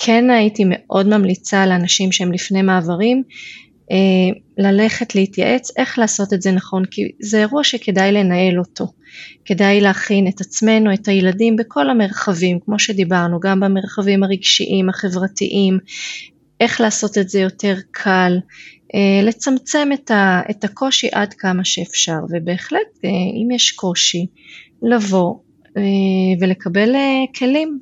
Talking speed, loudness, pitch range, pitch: 120 wpm, -16 LUFS, 190-225 Hz, 200 Hz